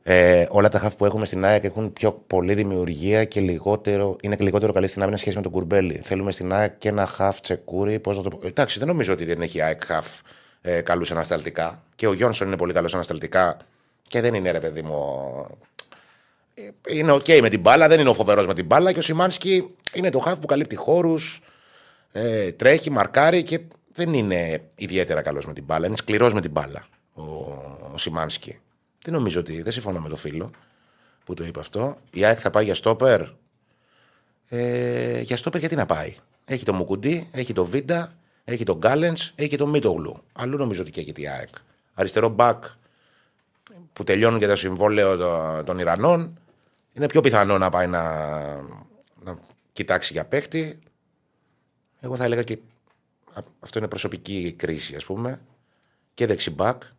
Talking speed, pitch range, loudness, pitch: 185 wpm, 90-135 Hz, -22 LUFS, 105 Hz